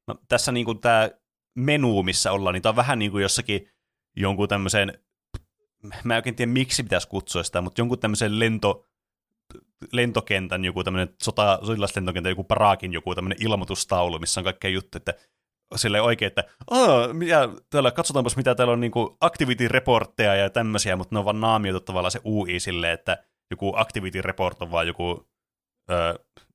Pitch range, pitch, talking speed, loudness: 95-120 Hz, 100 Hz, 165 wpm, -23 LUFS